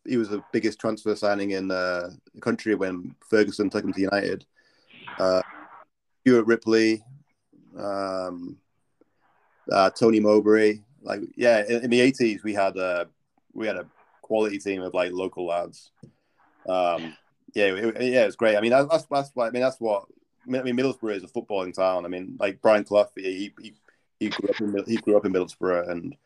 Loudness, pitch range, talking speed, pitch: -24 LUFS, 95-115 Hz, 185 wpm, 105 Hz